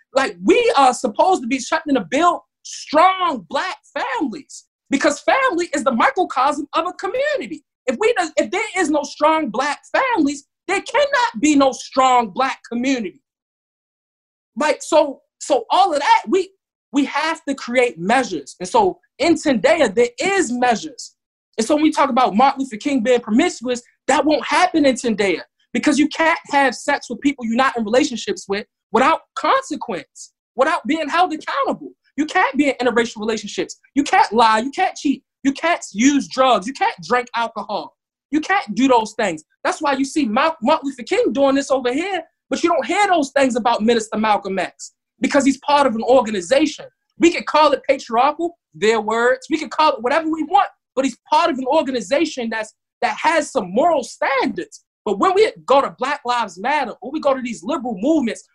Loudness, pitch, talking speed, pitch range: -18 LUFS, 280 Hz, 190 wpm, 250-320 Hz